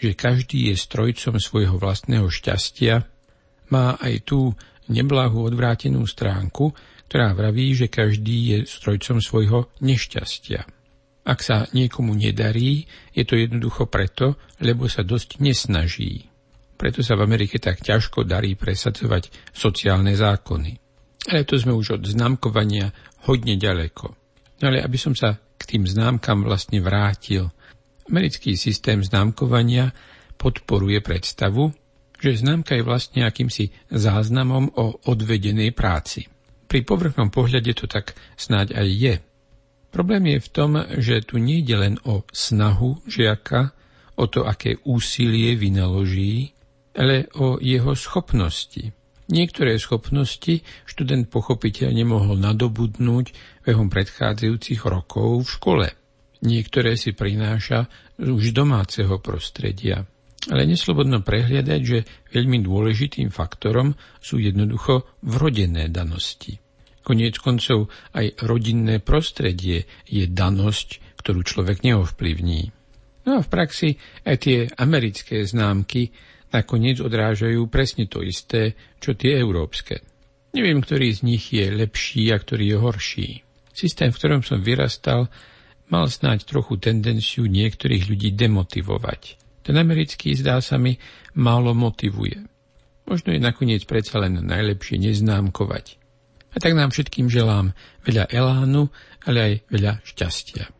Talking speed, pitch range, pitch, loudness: 120 wpm, 105-130 Hz, 115 Hz, -21 LUFS